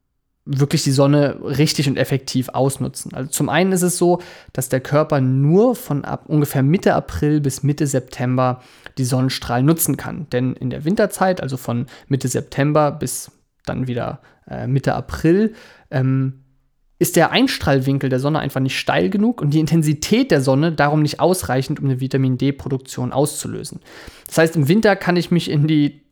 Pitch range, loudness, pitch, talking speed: 130-160 Hz, -18 LUFS, 145 Hz, 170 wpm